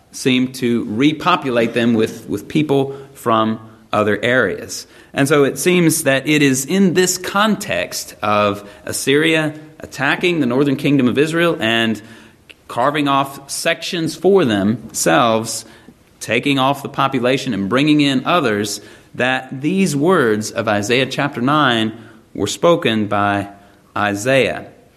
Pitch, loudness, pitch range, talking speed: 130 Hz, -16 LUFS, 110-150 Hz, 125 wpm